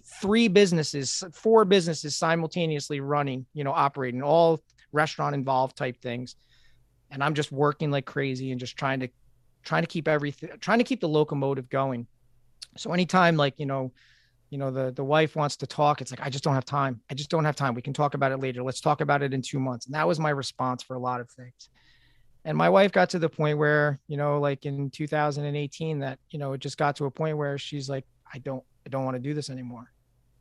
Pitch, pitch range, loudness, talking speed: 140 Hz, 130-150 Hz, -26 LUFS, 230 wpm